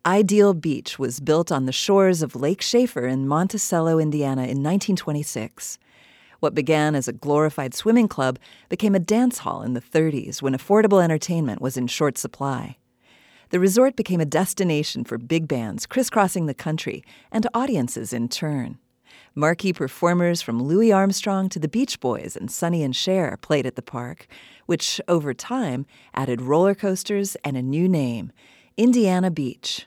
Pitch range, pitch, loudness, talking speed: 135-195 Hz, 160 Hz, -22 LUFS, 160 wpm